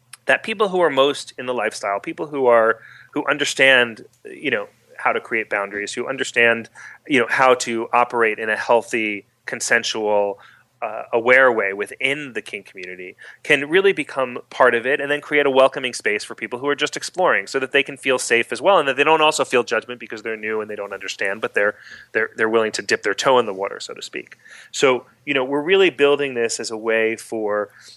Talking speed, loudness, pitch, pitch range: 220 wpm, -19 LUFS, 120 Hz, 110-145 Hz